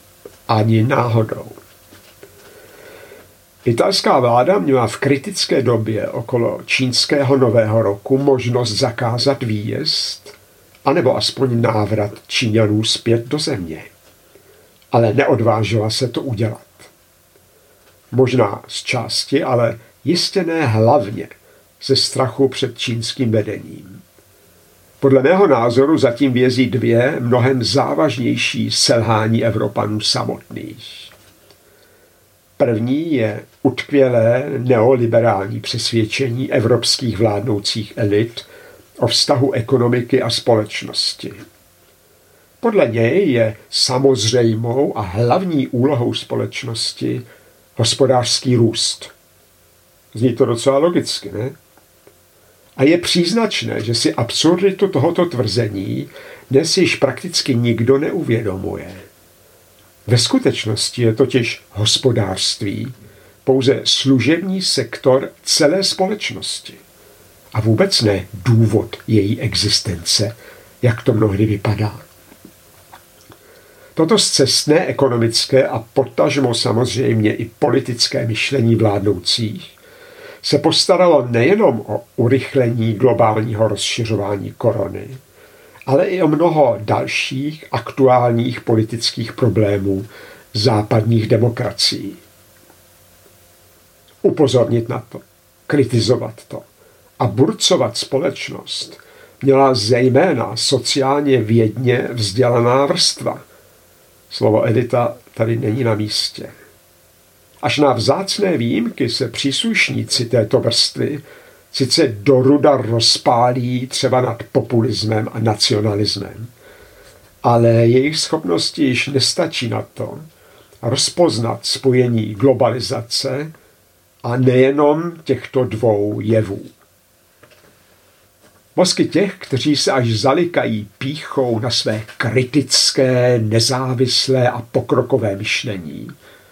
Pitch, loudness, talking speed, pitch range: 120 Hz, -16 LUFS, 90 wpm, 110-135 Hz